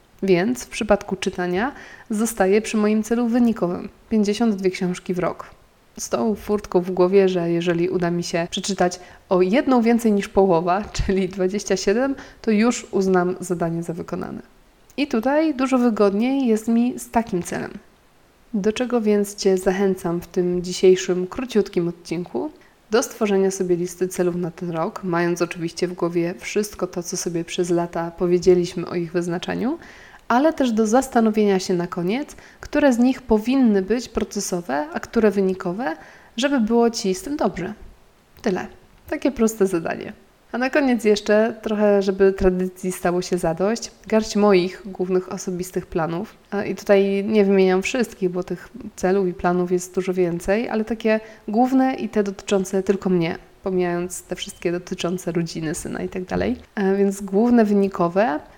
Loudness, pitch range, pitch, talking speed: -21 LUFS, 180-220 Hz, 195 Hz, 155 wpm